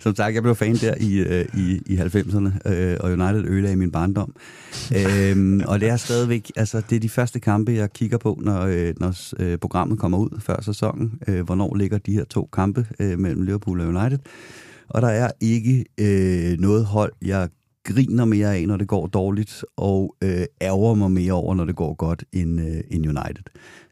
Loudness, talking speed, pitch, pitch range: -22 LUFS, 175 wpm, 100 Hz, 90-110 Hz